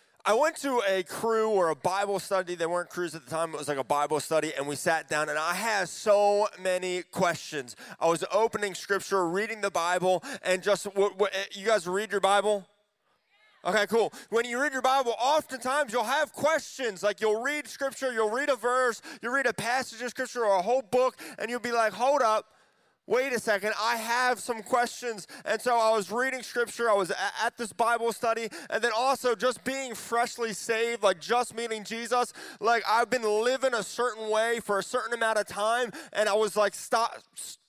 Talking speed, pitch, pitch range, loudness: 205 wpm, 225 Hz, 200-245 Hz, -28 LUFS